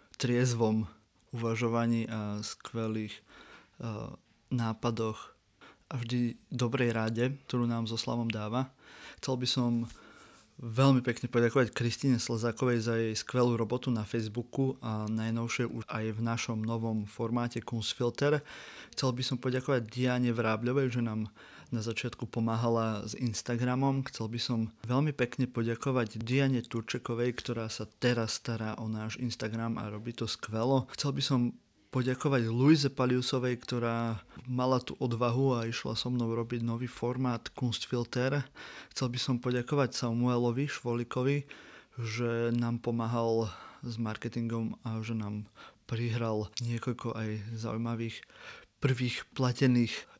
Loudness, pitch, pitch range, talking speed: -32 LUFS, 120 Hz, 115-125 Hz, 130 wpm